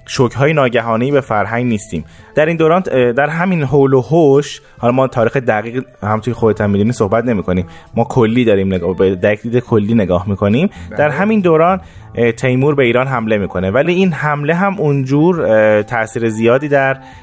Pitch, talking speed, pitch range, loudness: 120 Hz, 170 wpm, 110-145 Hz, -14 LUFS